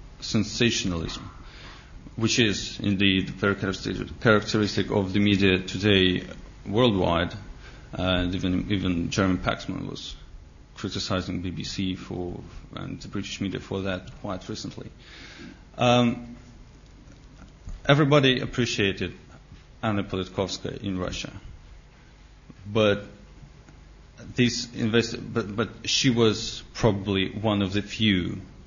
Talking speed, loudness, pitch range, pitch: 100 wpm, -25 LUFS, 95-115 Hz, 100 Hz